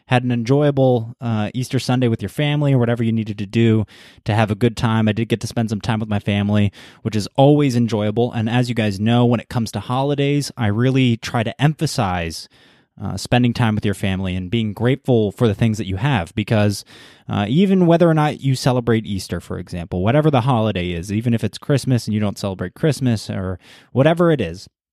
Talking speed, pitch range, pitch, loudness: 220 wpm, 105-125 Hz, 115 Hz, -19 LUFS